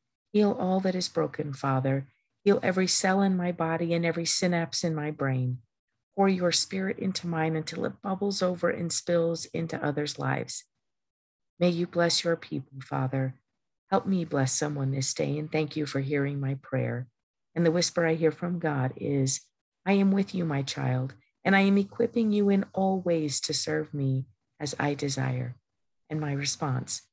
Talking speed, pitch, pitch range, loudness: 180 wpm, 160 Hz, 135-180 Hz, -28 LUFS